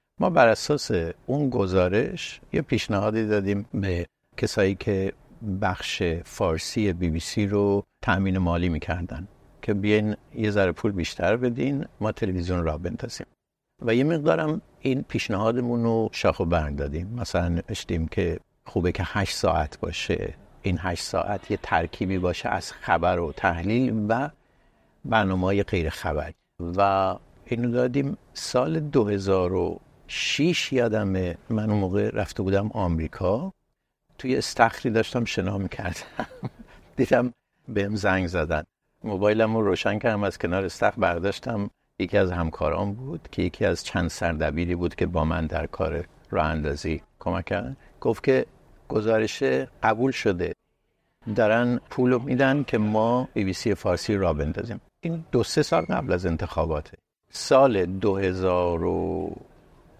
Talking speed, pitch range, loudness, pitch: 135 wpm, 90-115 Hz, -25 LUFS, 100 Hz